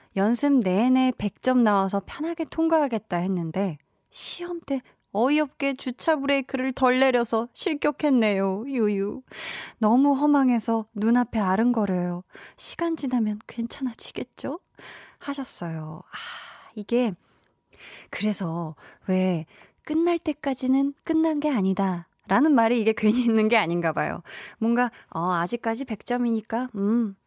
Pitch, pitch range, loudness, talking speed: 235 Hz, 200-275 Hz, -25 LUFS, 265 characters per minute